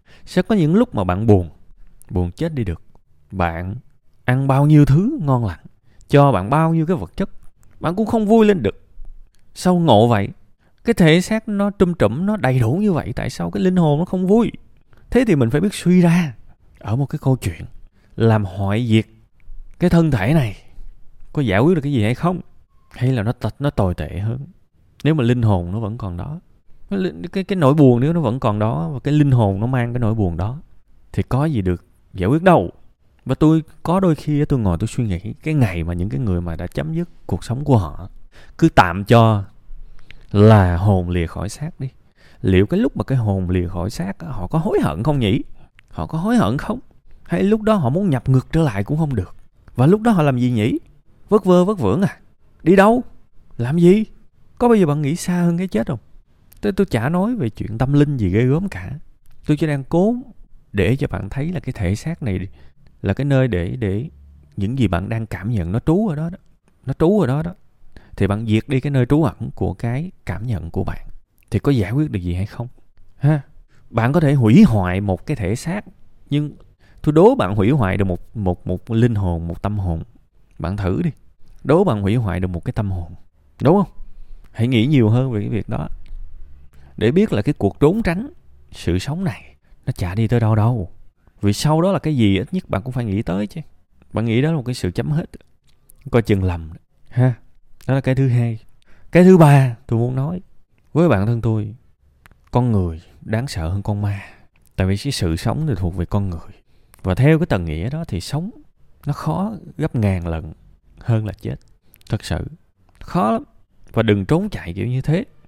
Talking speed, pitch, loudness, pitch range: 225 wpm, 115 Hz, -18 LUFS, 95-150 Hz